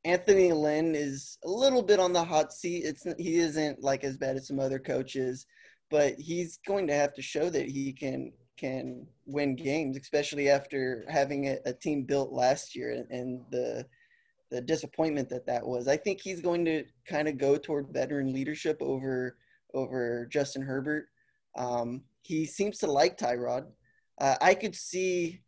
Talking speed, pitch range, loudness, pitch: 175 wpm, 135-170 Hz, -30 LUFS, 145 Hz